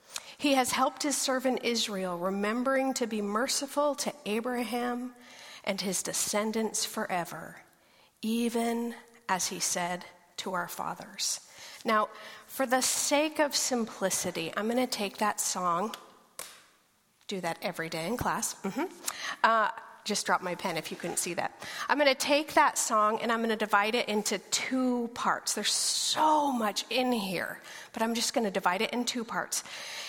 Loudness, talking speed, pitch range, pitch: -30 LUFS, 165 wpm, 205-260 Hz, 230 Hz